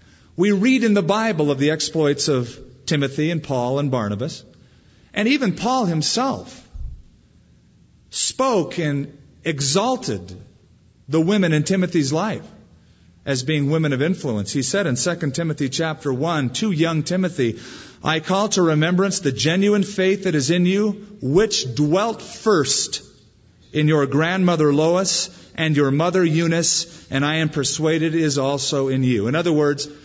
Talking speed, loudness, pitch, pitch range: 150 wpm, -20 LUFS, 155 Hz, 140-180 Hz